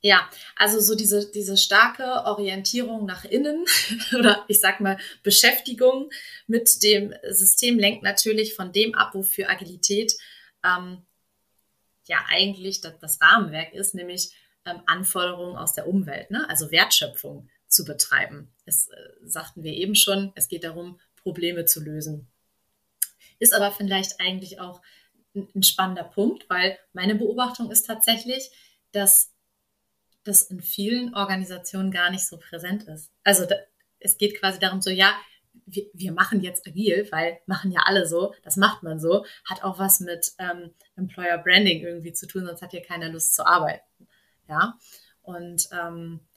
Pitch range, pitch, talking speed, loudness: 175-210 Hz, 190 Hz, 155 wpm, -21 LUFS